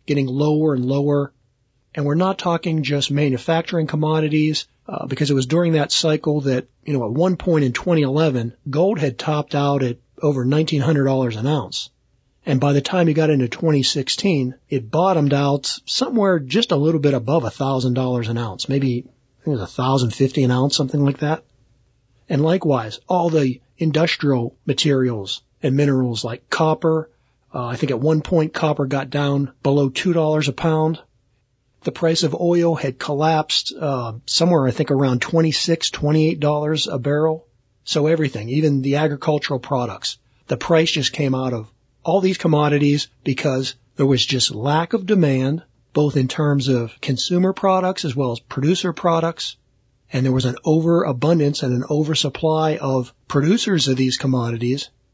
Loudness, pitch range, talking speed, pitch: -19 LUFS, 130-155 Hz, 165 wpm, 145 Hz